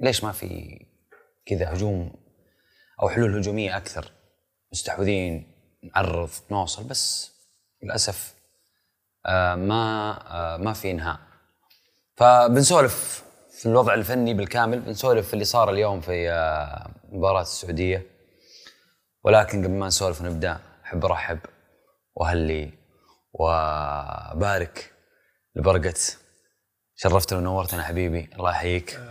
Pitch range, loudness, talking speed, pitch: 85-105 Hz, -23 LUFS, 95 wpm, 95 Hz